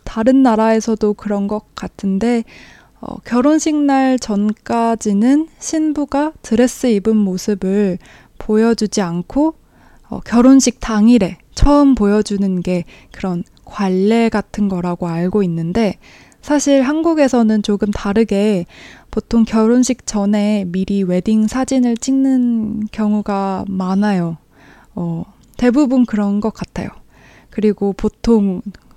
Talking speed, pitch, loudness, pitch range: 240 characters per minute, 215 Hz, -15 LUFS, 200-245 Hz